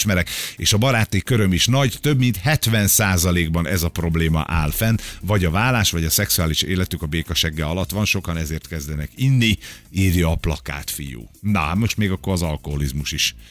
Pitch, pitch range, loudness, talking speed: 90 Hz, 80-105 Hz, -20 LUFS, 180 wpm